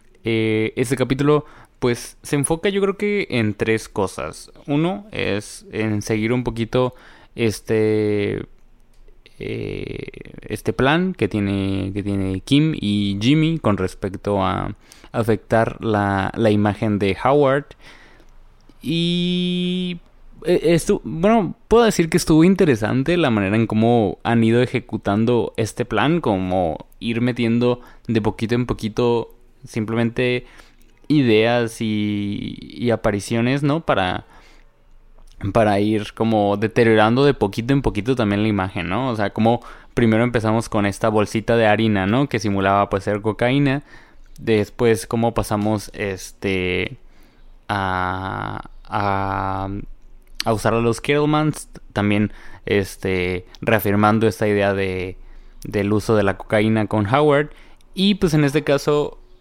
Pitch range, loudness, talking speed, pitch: 105-130 Hz, -20 LUFS, 125 wpm, 110 Hz